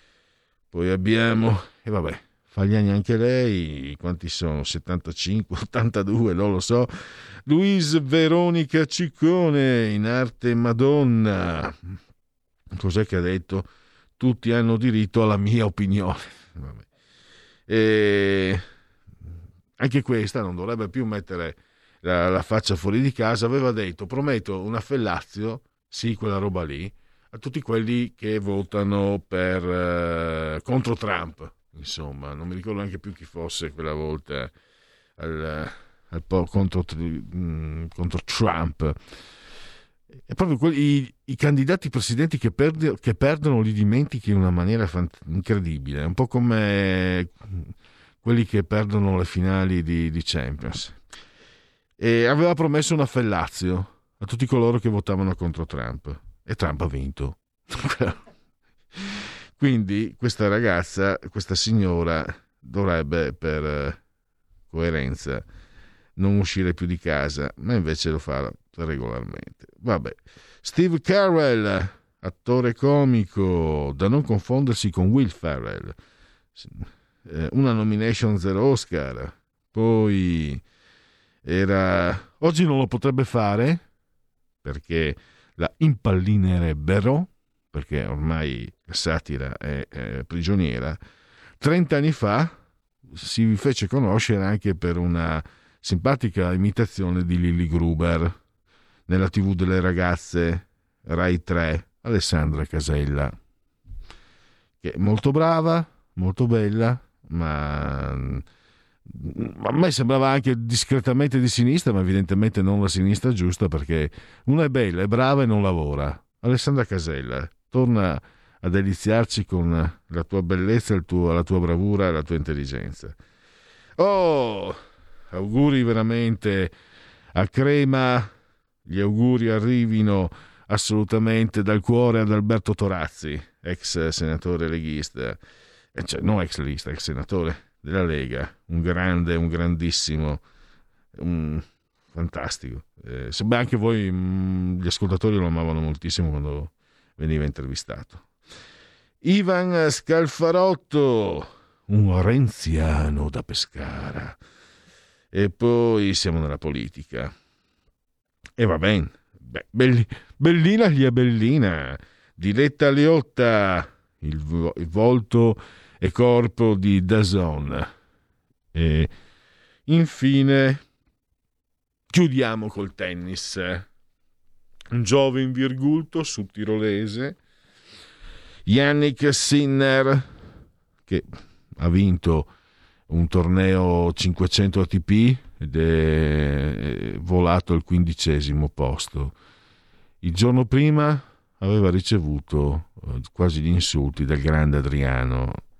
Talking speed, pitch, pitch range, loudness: 110 wpm, 95 Hz, 85-115 Hz, -23 LUFS